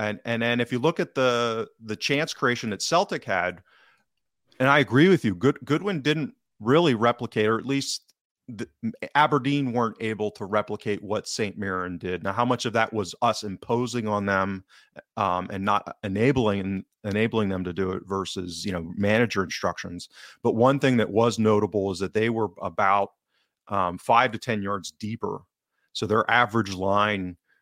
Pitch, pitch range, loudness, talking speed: 110 Hz, 100-120 Hz, -25 LUFS, 180 wpm